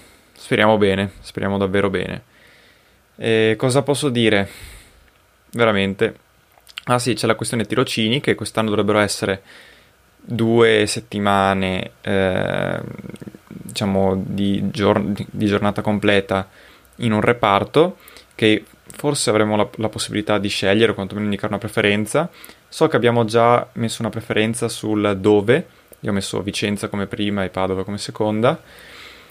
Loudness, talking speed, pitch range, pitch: -19 LUFS, 130 wpm, 100-115 Hz, 105 Hz